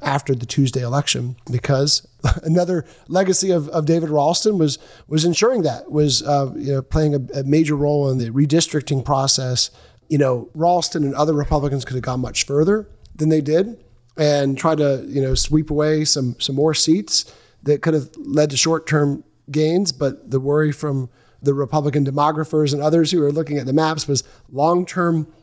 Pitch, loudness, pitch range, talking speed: 150 Hz, -19 LUFS, 135-160 Hz, 185 wpm